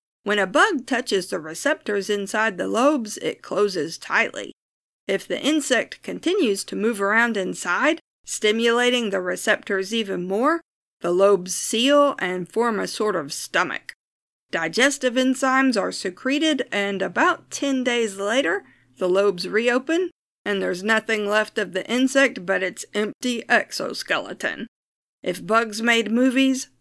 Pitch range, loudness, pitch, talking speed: 200-265 Hz, -22 LUFS, 230 Hz, 135 wpm